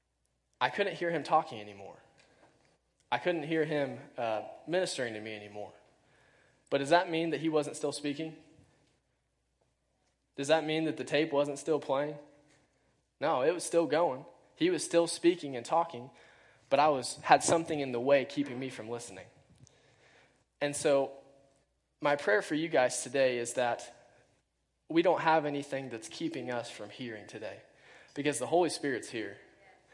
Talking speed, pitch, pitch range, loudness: 160 wpm, 145 Hz, 125-160 Hz, -32 LUFS